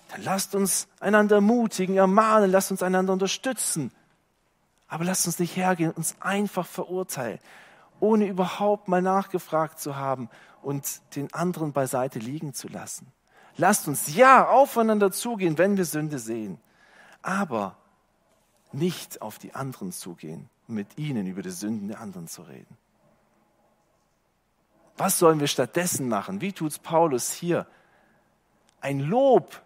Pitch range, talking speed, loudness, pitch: 145-195 Hz, 140 wpm, -24 LUFS, 180 Hz